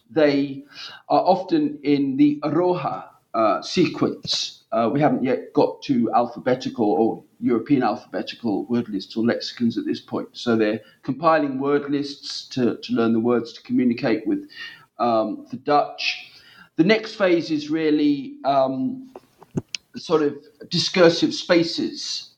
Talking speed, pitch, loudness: 135 wpm, 170 Hz, -22 LUFS